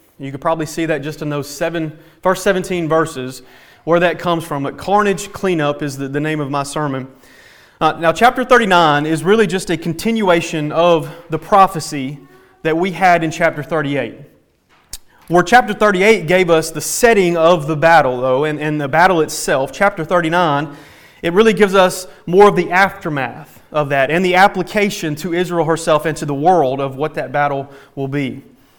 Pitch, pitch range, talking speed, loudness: 165 Hz, 150-185 Hz, 185 wpm, -15 LUFS